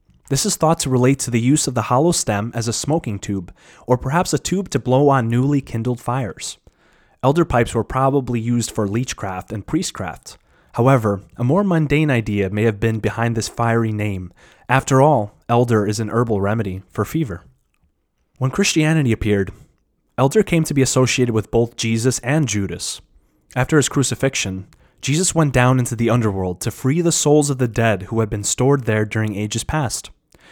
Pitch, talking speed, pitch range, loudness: 120 Hz, 185 wpm, 110-140 Hz, -19 LUFS